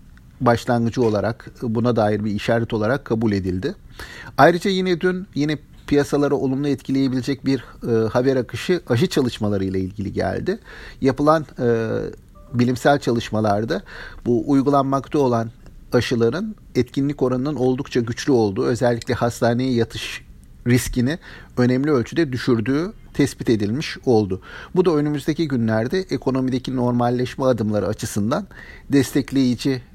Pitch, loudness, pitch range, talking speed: 125 Hz, -21 LUFS, 115-140 Hz, 115 wpm